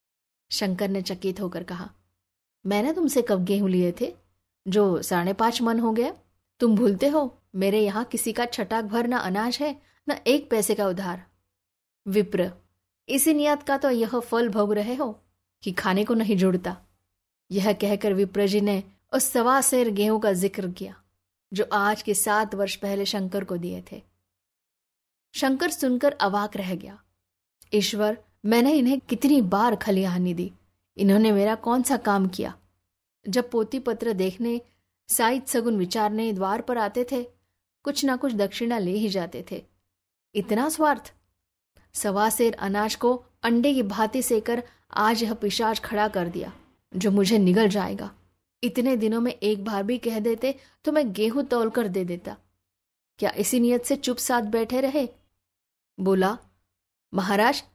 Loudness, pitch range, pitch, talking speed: -24 LUFS, 185-240 Hz, 210 Hz, 160 wpm